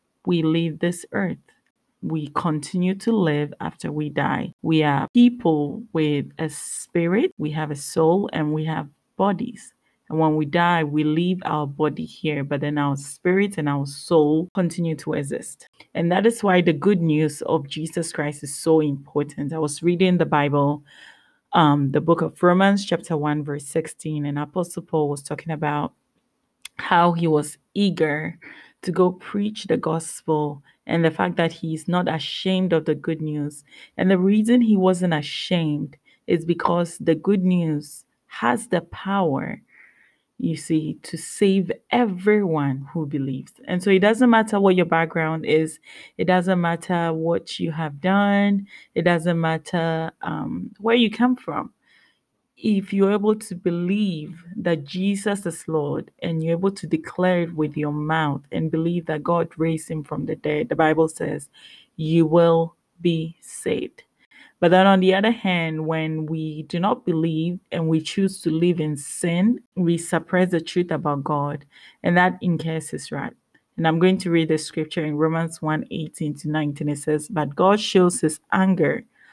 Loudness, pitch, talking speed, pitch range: -22 LUFS, 165 Hz, 170 wpm, 155-185 Hz